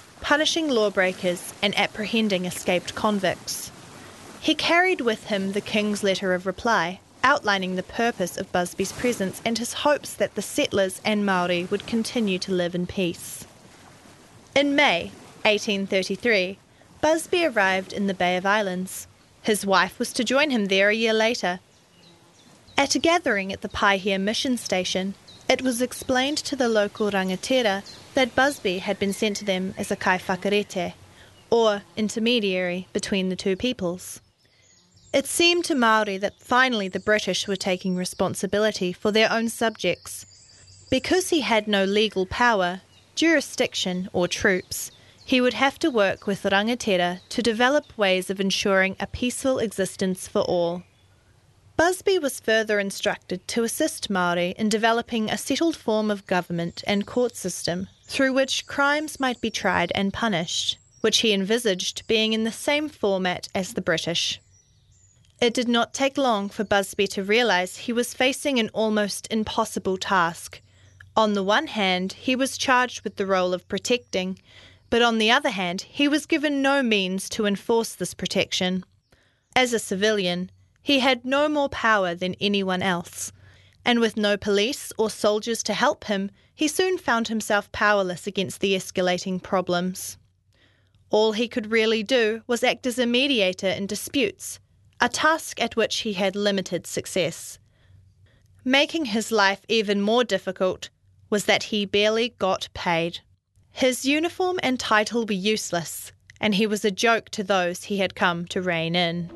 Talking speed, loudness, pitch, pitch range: 155 wpm, -23 LUFS, 205 Hz, 185-235 Hz